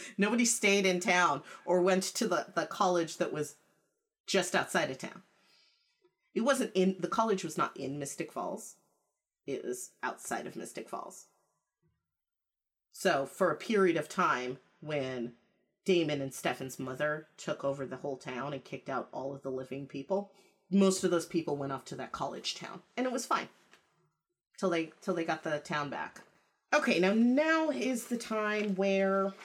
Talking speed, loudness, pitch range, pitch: 175 wpm, -32 LUFS, 145-210 Hz, 180 Hz